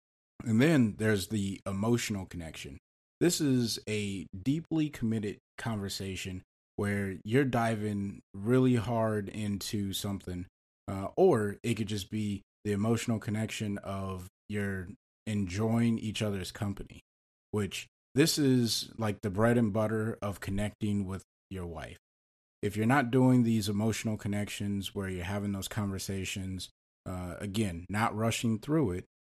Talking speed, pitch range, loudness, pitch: 135 wpm, 95-115 Hz, -32 LUFS, 105 Hz